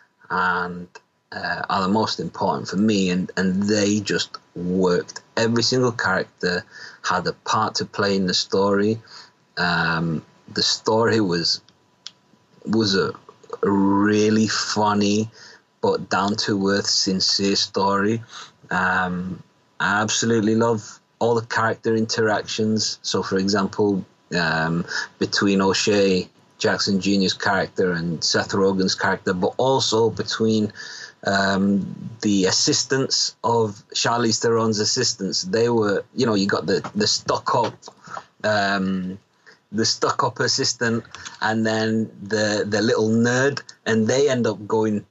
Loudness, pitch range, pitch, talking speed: -21 LUFS, 95-110 Hz, 105 Hz, 125 wpm